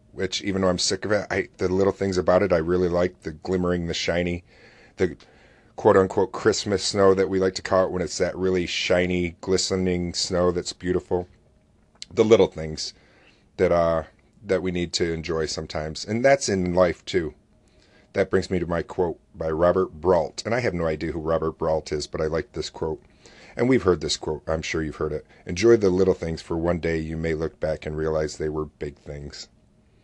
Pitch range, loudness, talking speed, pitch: 80-95 Hz, -24 LUFS, 210 wpm, 90 Hz